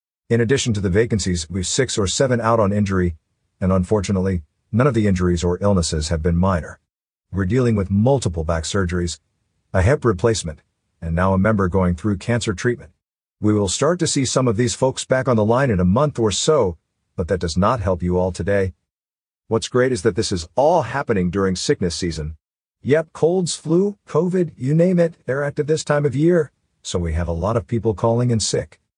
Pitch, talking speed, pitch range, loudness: 105 Hz, 205 wpm, 90-125 Hz, -19 LUFS